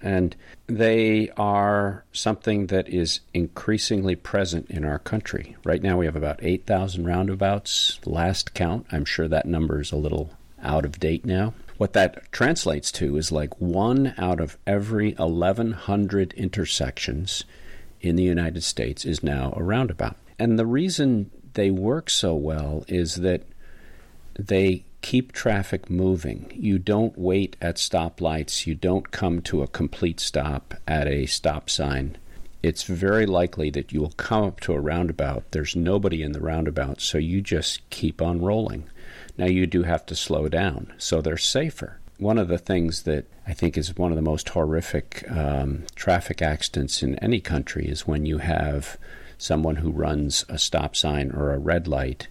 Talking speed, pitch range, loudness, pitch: 165 wpm, 75-100 Hz, -24 LUFS, 85 Hz